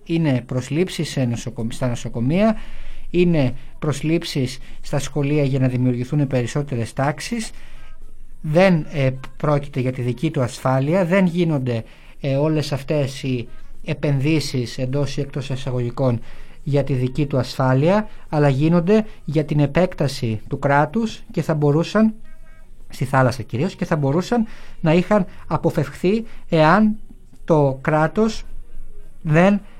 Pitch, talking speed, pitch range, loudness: 145 Hz, 125 wpm, 130-170 Hz, -20 LUFS